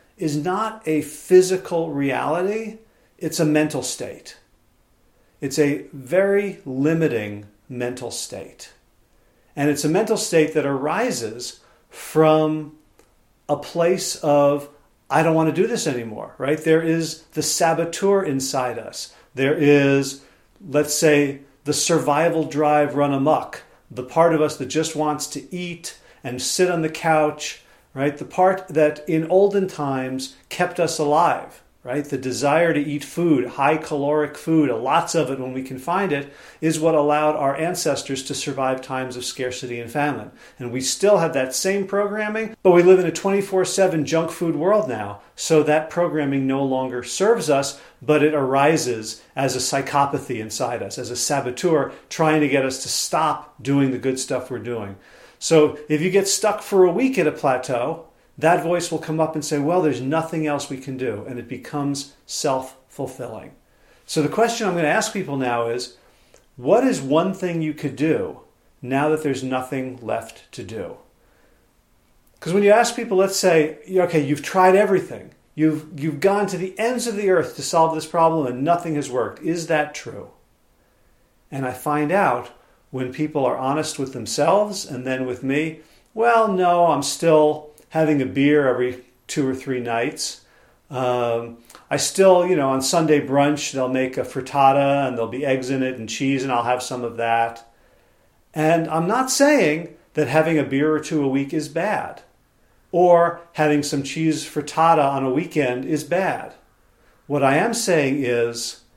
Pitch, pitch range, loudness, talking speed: 150 Hz, 135-165 Hz, -20 LUFS, 175 wpm